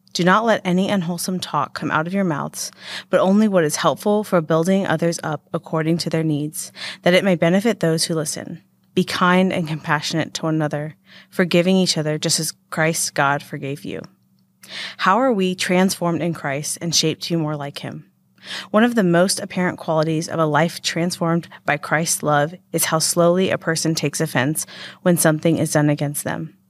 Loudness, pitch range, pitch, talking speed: -19 LUFS, 155-185 Hz, 165 Hz, 190 wpm